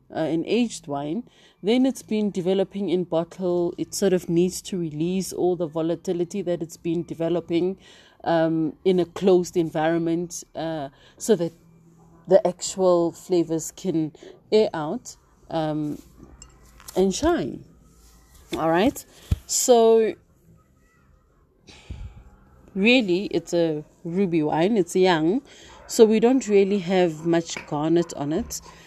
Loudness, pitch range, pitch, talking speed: -23 LUFS, 160-190 Hz, 170 Hz, 125 wpm